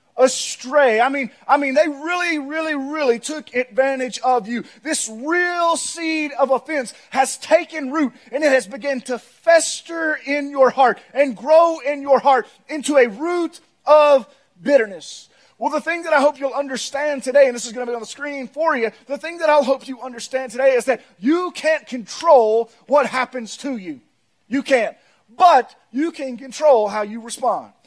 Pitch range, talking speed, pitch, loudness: 255-305 Hz, 185 wpm, 275 Hz, -19 LUFS